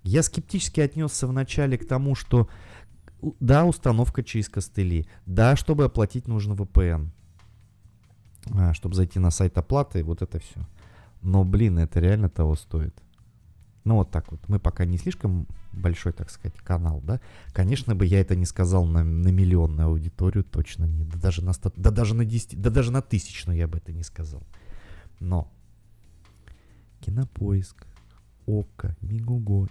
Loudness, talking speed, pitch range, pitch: -25 LUFS, 160 wpm, 85-110 Hz, 95 Hz